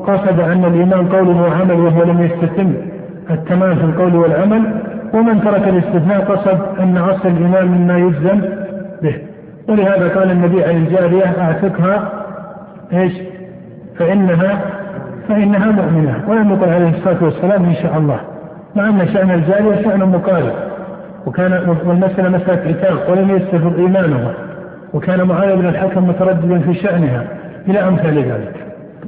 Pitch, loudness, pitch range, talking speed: 185 Hz, -13 LUFS, 175-195 Hz, 130 wpm